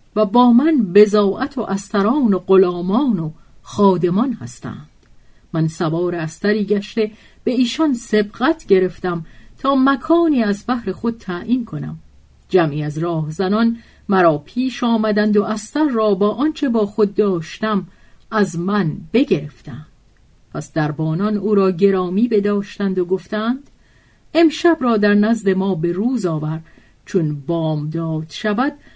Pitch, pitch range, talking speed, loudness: 205 Hz, 175-230 Hz, 135 wpm, -18 LUFS